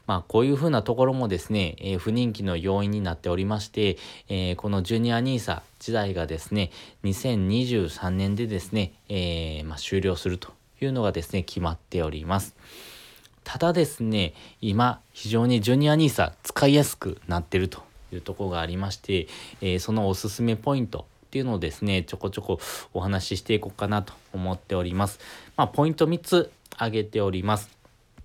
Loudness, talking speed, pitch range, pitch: -26 LUFS, 370 characters per minute, 95-115 Hz, 100 Hz